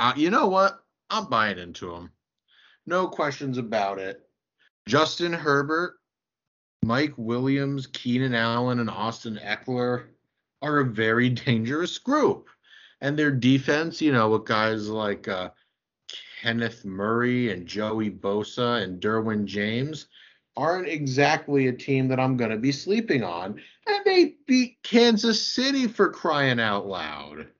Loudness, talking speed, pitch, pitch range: -25 LUFS, 135 wpm, 130 Hz, 110-155 Hz